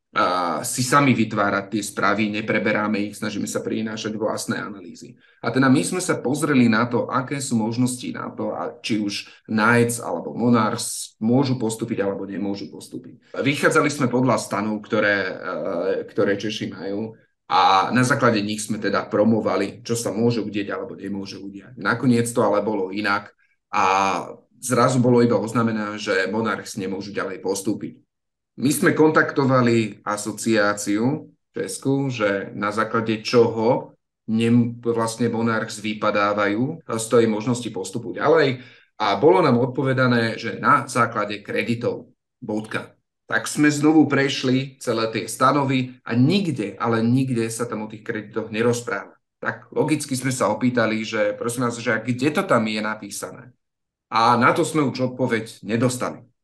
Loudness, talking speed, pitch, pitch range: -21 LUFS, 150 wpm, 115 Hz, 105-125 Hz